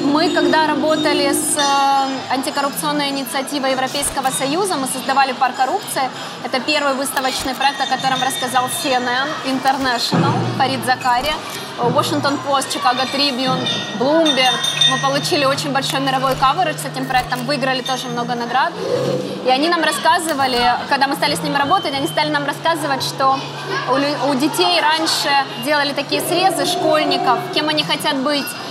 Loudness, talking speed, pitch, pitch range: -17 LUFS, 140 wpm, 275 Hz, 260-305 Hz